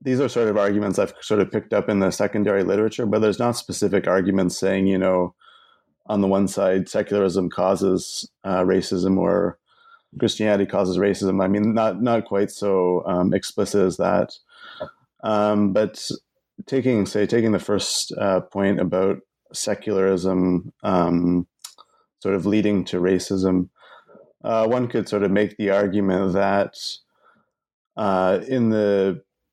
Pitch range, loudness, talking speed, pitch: 95-105 Hz, -21 LUFS, 150 wpm, 100 Hz